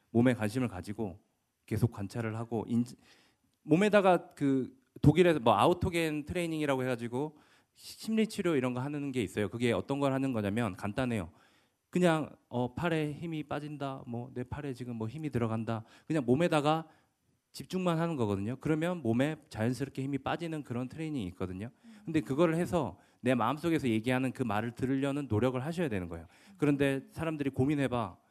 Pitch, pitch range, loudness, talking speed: 135 Hz, 120-155 Hz, -32 LUFS, 380 characters per minute